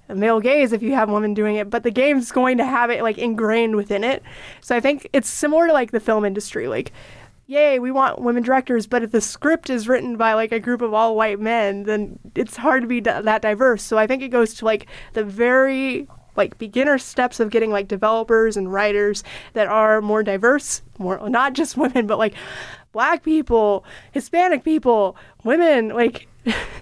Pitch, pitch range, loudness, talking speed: 235 Hz, 215-265 Hz, -19 LUFS, 205 wpm